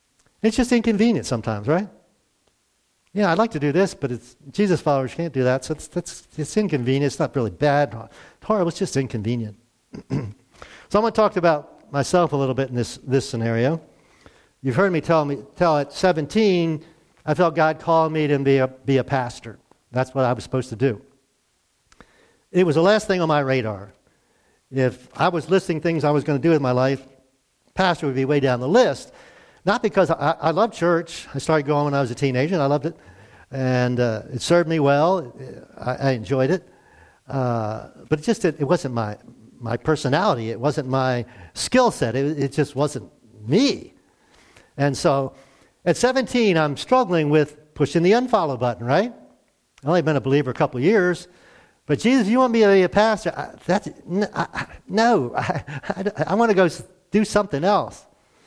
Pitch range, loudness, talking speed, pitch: 130-180 Hz, -21 LUFS, 200 wpm, 150 Hz